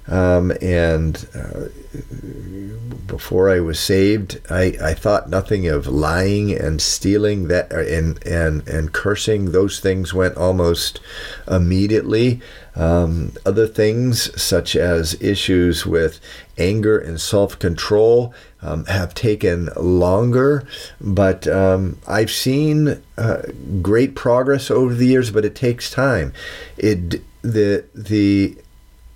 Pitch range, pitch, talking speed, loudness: 85-110 Hz, 95 Hz, 115 wpm, -18 LUFS